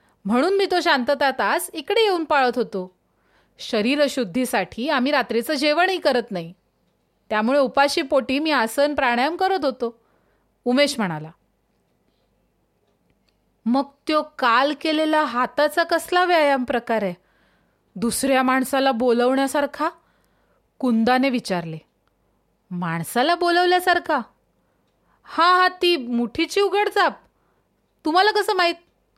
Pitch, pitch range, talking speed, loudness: 280 Hz, 240-330 Hz, 105 wpm, -20 LUFS